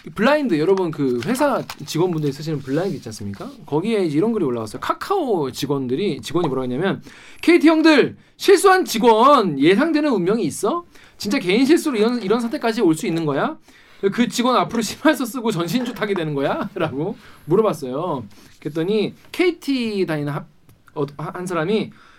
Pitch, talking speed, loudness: 205 Hz, 375 characters per minute, -19 LUFS